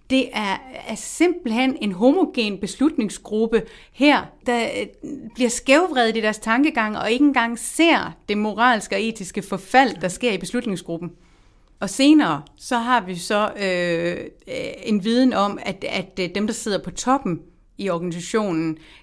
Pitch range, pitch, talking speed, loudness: 190-255 Hz, 225 Hz, 145 wpm, -21 LUFS